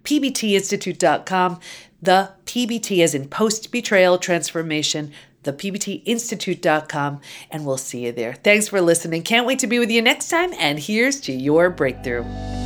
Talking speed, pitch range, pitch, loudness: 145 wpm, 150-220 Hz, 180 Hz, -20 LUFS